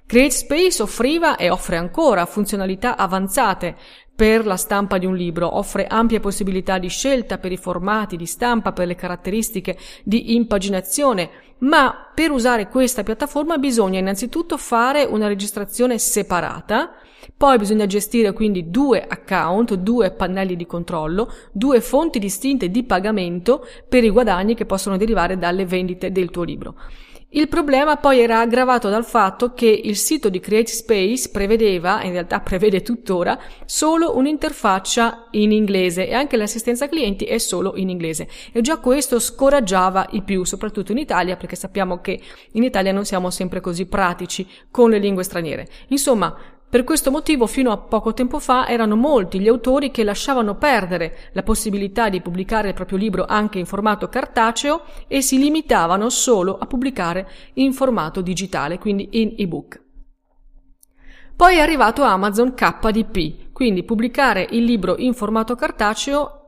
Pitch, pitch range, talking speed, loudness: 215 Hz, 190-255 Hz, 150 wpm, -18 LUFS